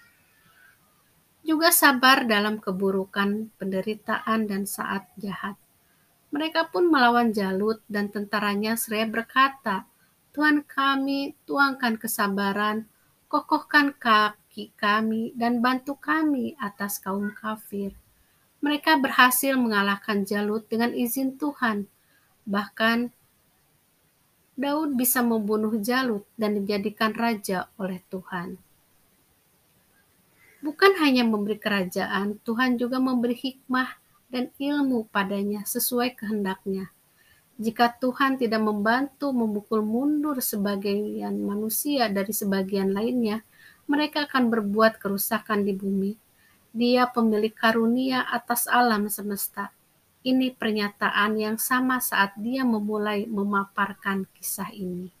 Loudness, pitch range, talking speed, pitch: -25 LUFS, 205-255 Hz, 100 wpm, 220 Hz